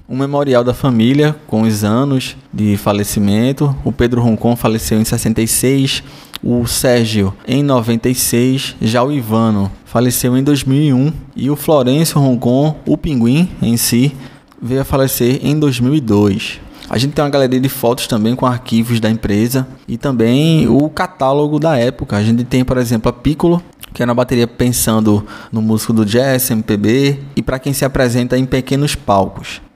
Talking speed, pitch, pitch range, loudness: 165 wpm, 125 Hz, 115-135 Hz, -14 LUFS